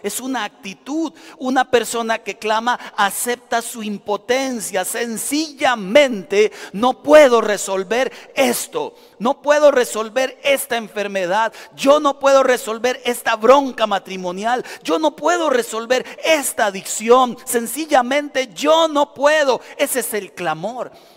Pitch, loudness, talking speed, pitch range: 245 Hz, -18 LUFS, 115 wpm, 215-280 Hz